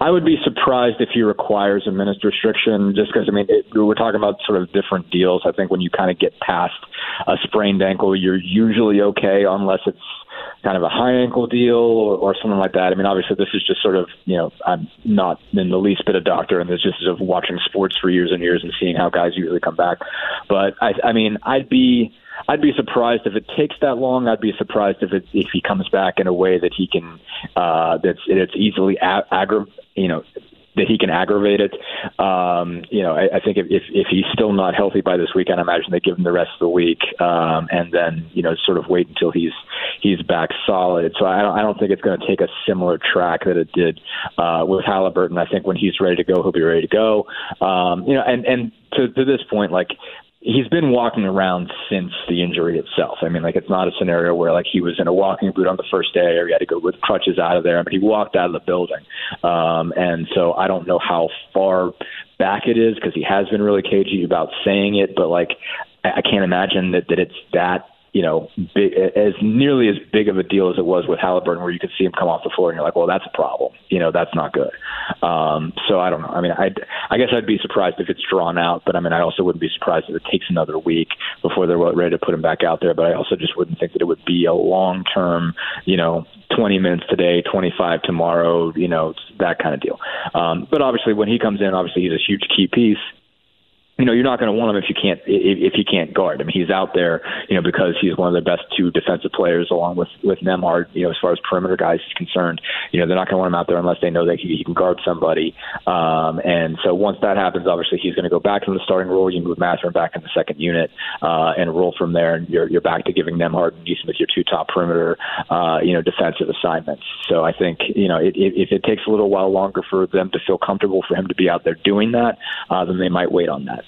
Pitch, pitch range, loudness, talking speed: 95 Hz, 85-105 Hz, -18 LUFS, 260 wpm